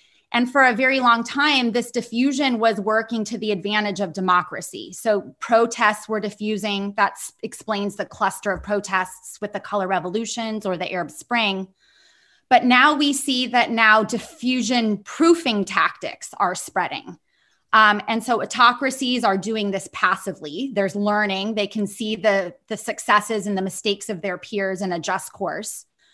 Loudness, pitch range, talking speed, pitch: -21 LUFS, 200-240 Hz, 160 wpm, 215 Hz